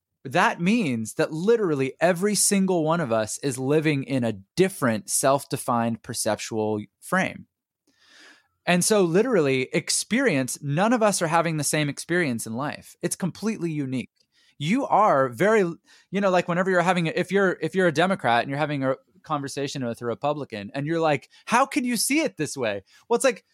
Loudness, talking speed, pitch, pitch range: -24 LUFS, 180 wpm, 160 Hz, 135-185 Hz